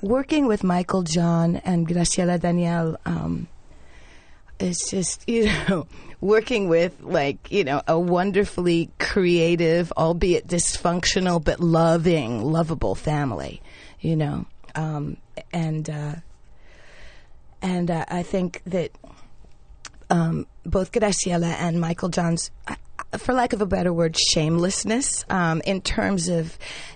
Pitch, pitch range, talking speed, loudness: 170 Hz, 160-185 Hz, 120 wpm, -23 LUFS